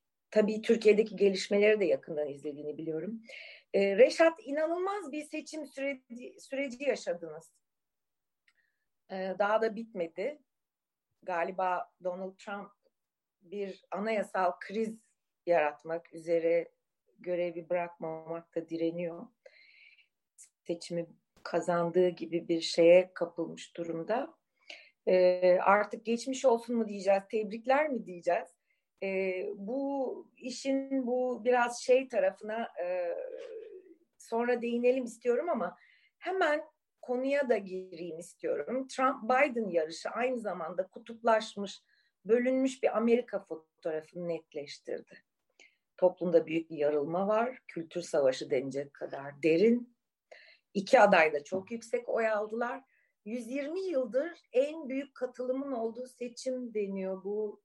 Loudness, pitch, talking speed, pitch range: -31 LUFS, 220 Hz, 105 wpm, 175-260 Hz